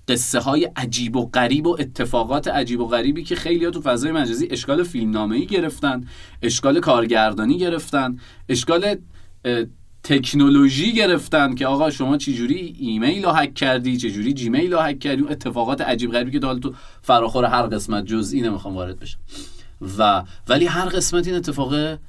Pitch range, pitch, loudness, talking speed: 120-160 Hz, 135 Hz, -20 LUFS, 160 wpm